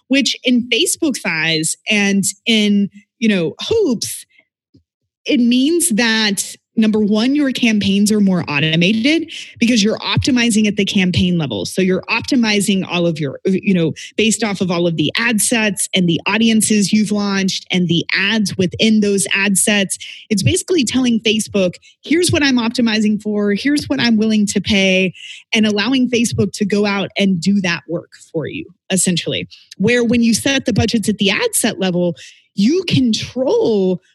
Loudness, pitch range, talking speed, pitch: -15 LUFS, 190-235 Hz, 165 wpm, 210 Hz